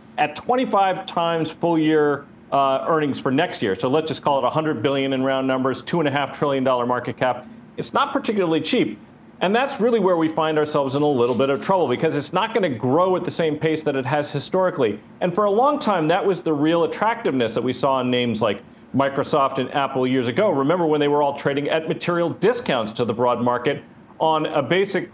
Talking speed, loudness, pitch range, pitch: 220 wpm, -21 LUFS, 135-175 Hz, 150 Hz